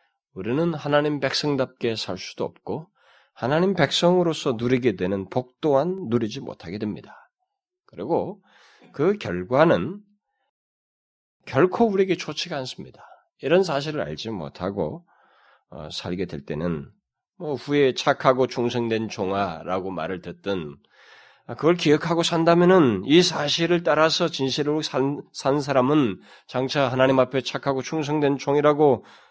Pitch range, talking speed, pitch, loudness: 120-165 Hz, 275 characters per minute, 140 Hz, -23 LUFS